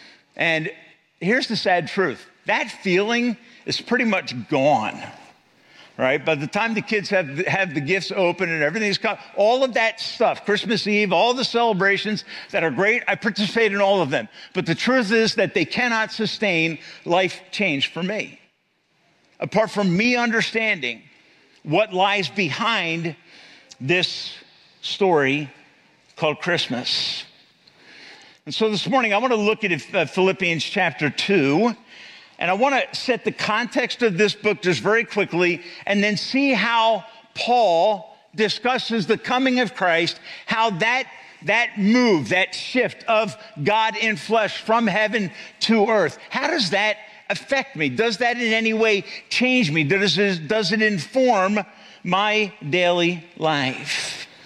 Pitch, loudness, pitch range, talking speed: 210 Hz, -21 LUFS, 180-225 Hz, 150 wpm